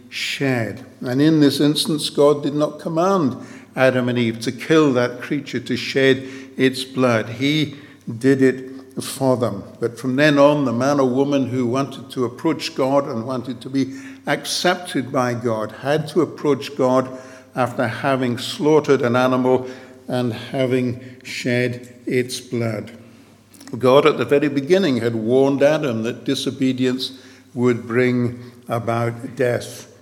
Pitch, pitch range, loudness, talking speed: 130 Hz, 125-140 Hz, -19 LUFS, 145 wpm